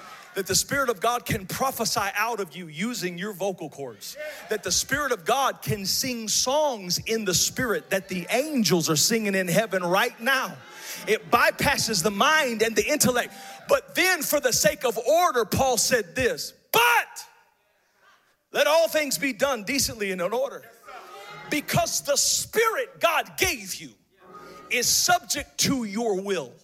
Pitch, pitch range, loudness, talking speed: 240 Hz, 195-300 Hz, -23 LUFS, 160 wpm